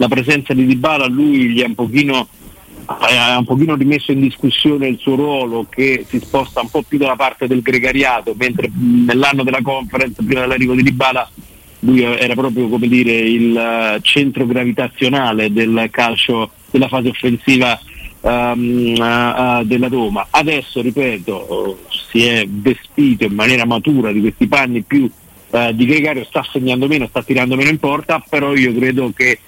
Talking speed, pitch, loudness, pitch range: 165 wpm, 130 Hz, -14 LUFS, 120-135 Hz